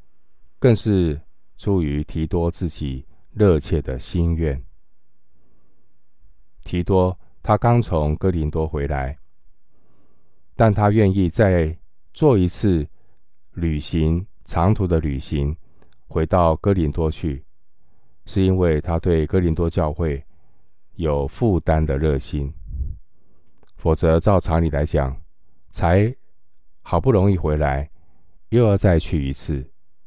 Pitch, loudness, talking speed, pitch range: 80 Hz, -20 LUFS, 160 characters per minute, 75-95 Hz